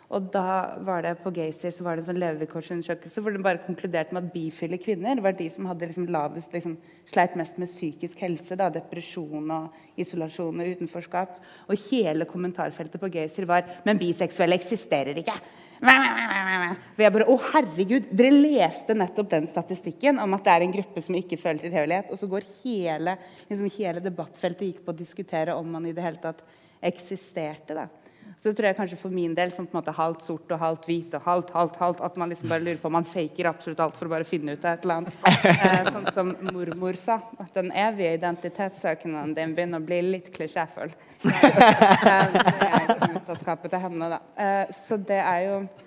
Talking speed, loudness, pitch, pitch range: 200 wpm, -25 LUFS, 175 Hz, 170-195 Hz